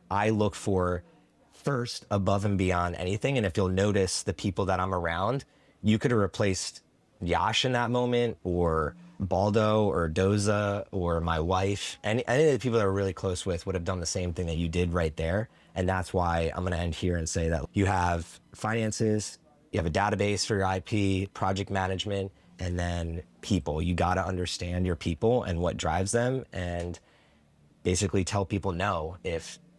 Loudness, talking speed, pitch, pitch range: -29 LUFS, 190 wpm, 95 Hz, 90-105 Hz